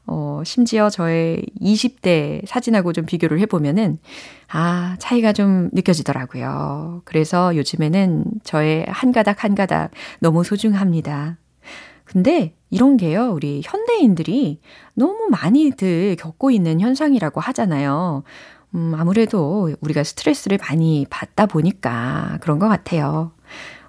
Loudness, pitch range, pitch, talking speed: -18 LUFS, 160-215 Hz, 180 Hz, 275 characters per minute